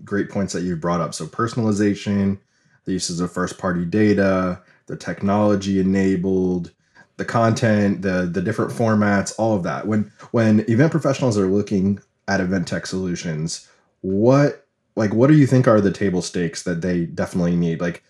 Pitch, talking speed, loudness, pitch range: 100 Hz, 170 wpm, -20 LUFS, 90-105 Hz